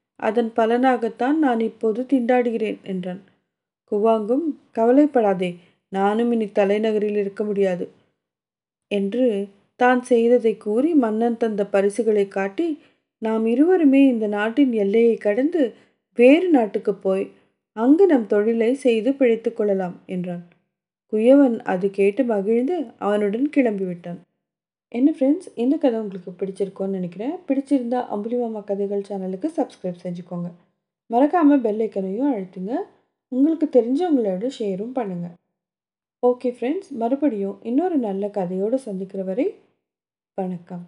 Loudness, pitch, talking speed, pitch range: -21 LUFS, 225 Hz, 105 wpm, 195-255 Hz